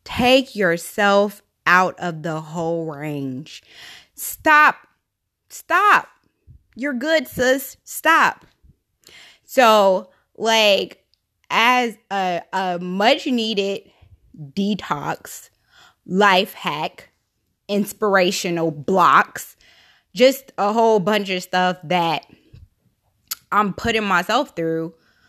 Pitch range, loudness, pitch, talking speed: 175-230 Hz, -18 LUFS, 200 Hz, 85 wpm